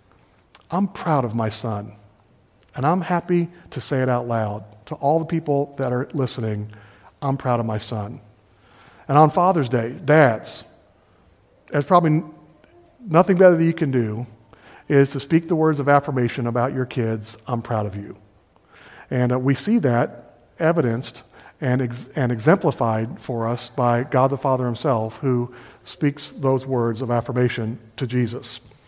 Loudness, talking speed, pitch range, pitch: -21 LUFS, 160 wpm, 115-150 Hz, 130 Hz